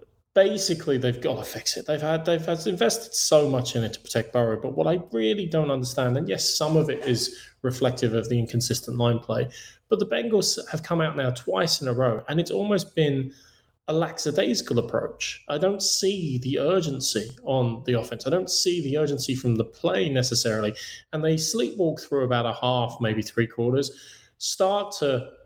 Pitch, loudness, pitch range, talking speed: 135 Hz, -25 LUFS, 120-170 Hz, 195 wpm